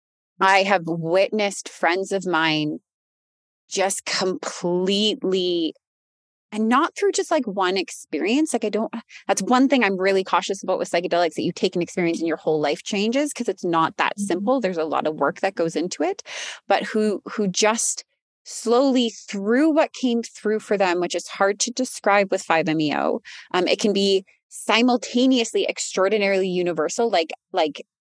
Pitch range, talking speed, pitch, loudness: 175-230 Hz, 165 wpm, 195 Hz, -22 LUFS